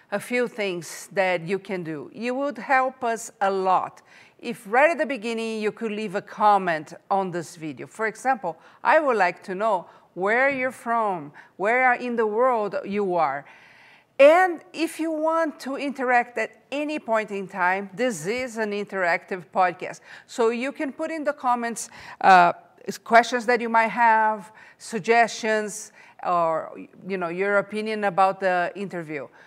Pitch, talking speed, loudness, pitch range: 220 Hz, 165 wpm, -23 LUFS, 195-250 Hz